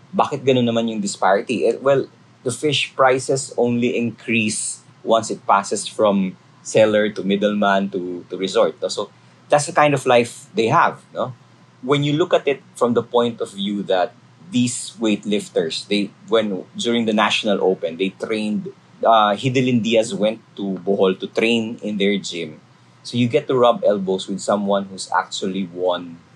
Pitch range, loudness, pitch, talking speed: 100-125 Hz, -19 LUFS, 110 Hz, 170 wpm